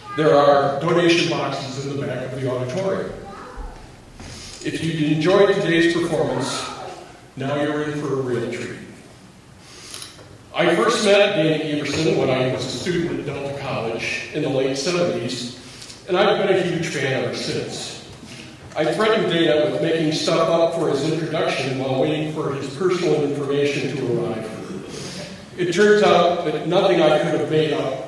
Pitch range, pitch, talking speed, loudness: 135-170 Hz, 150 Hz, 160 wpm, -20 LUFS